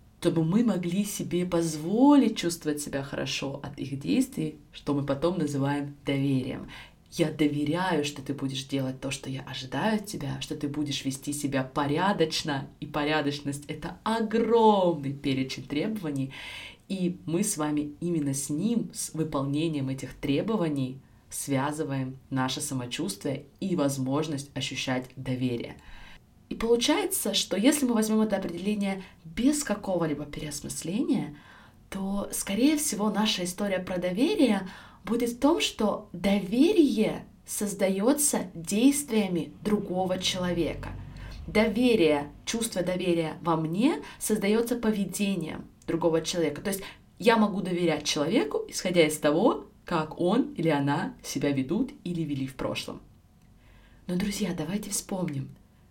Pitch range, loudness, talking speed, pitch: 145-205 Hz, -28 LUFS, 125 wpm, 165 Hz